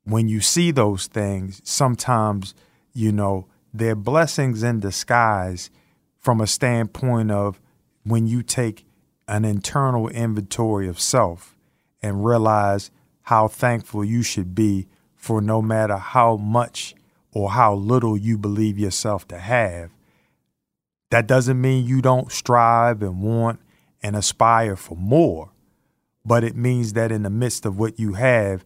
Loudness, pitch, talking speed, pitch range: -20 LUFS, 110 Hz, 140 wpm, 105-120 Hz